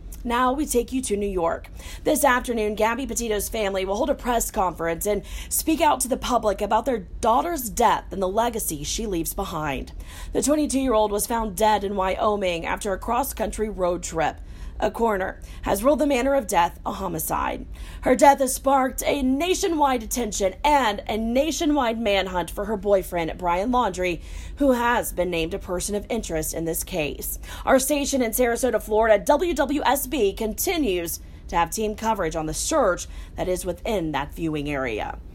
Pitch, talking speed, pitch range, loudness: 220 Hz, 180 wpm, 190-260 Hz, -23 LUFS